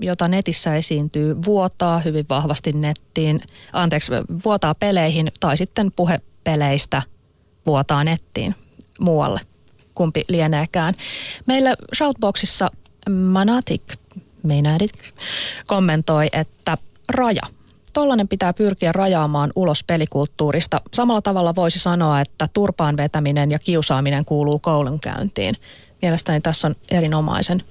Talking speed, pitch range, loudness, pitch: 100 wpm, 150-185 Hz, -20 LUFS, 160 Hz